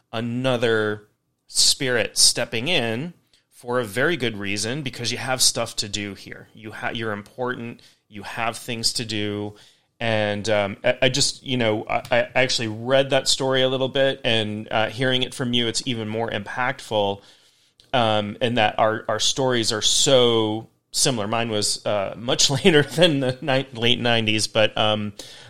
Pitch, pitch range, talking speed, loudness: 115 Hz, 110-130 Hz, 170 wpm, -21 LUFS